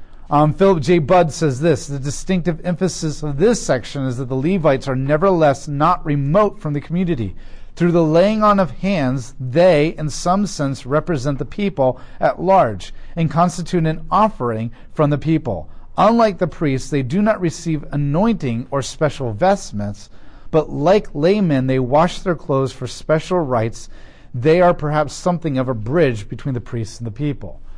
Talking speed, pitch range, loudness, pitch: 170 wpm, 130-175 Hz, -18 LUFS, 150 Hz